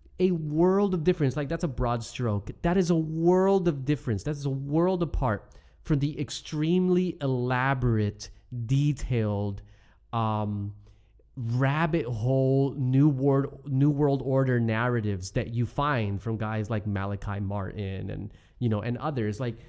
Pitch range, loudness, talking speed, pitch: 110-150 Hz, -27 LUFS, 145 wpm, 130 Hz